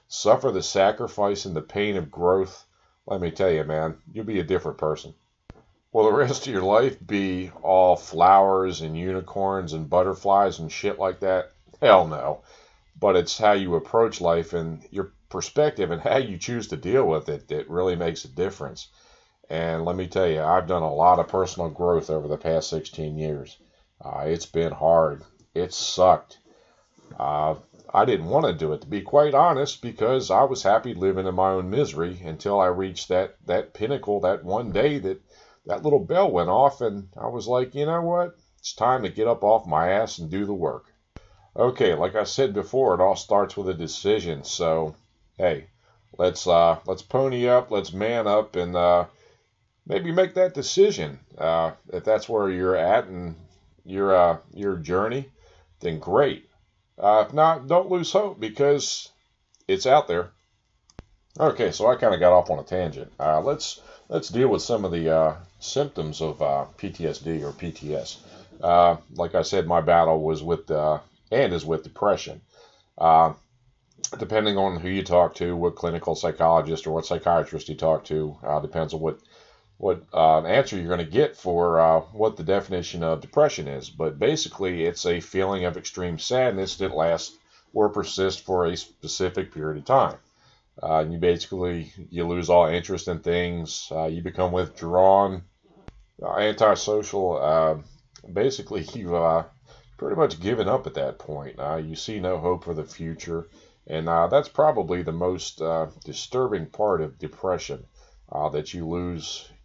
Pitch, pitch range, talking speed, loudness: 90 Hz, 80-100 Hz, 180 wpm, -23 LUFS